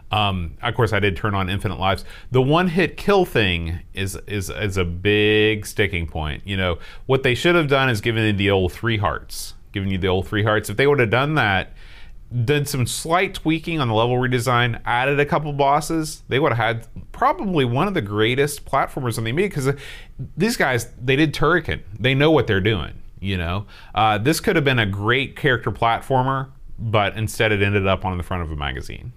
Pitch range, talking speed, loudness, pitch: 100-135 Hz, 215 wpm, -20 LUFS, 115 Hz